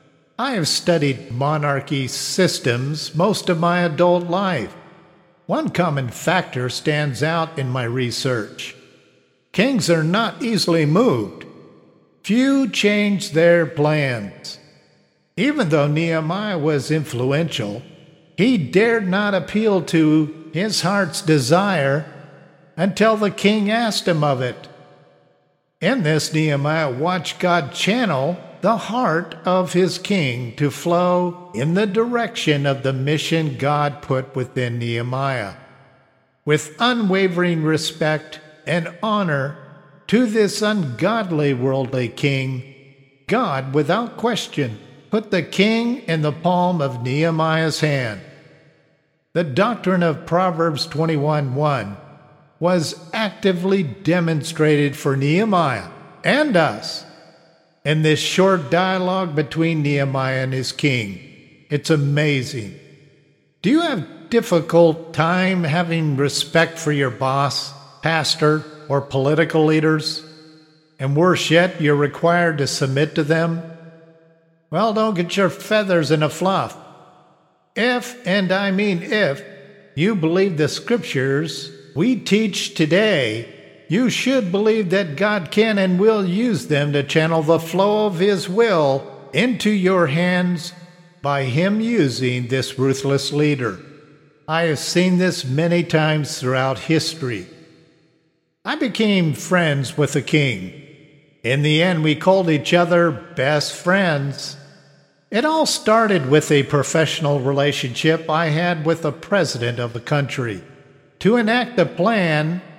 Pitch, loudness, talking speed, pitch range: 160 Hz, -19 LUFS, 120 wpm, 140-185 Hz